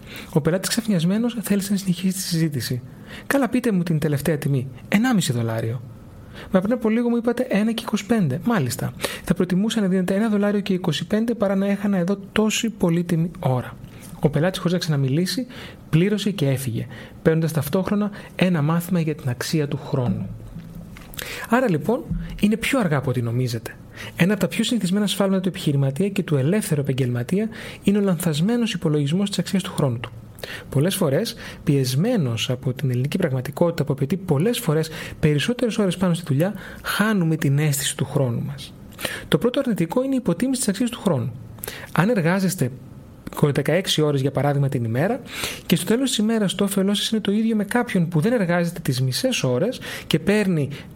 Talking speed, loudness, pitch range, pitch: 170 wpm, -22 LUFS, 145-205 Hz, 175 Hz